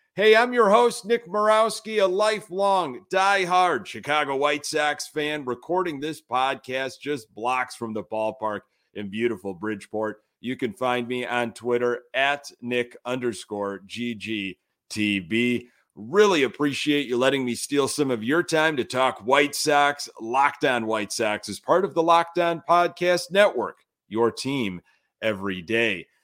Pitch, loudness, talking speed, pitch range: 130 Hz, -24 LUFS, 140 wpm, 115-170 Hz